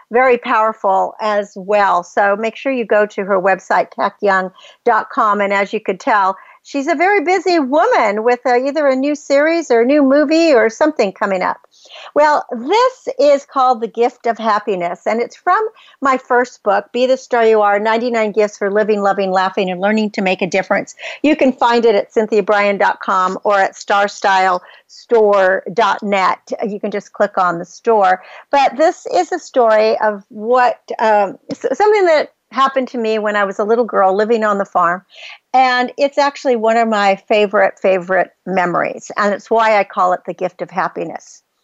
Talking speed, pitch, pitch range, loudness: 180 wpm, 220 Hz, 200-260 Hz, -15 LUFS